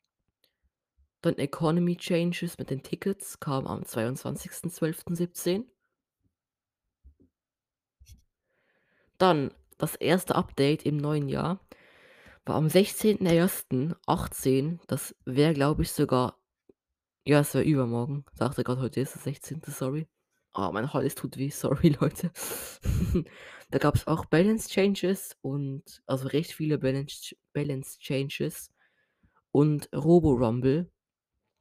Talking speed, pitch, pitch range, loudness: 115 wpm, 145 Hz, 130-170 Hz, -28 LUFS